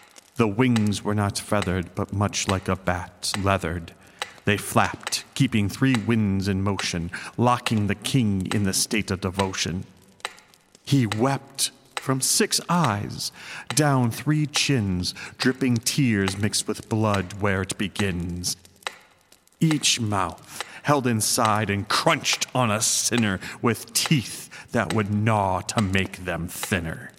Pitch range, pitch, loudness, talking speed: 95-125 Hz, 105 Hz, -24 LUFS, 130 wpm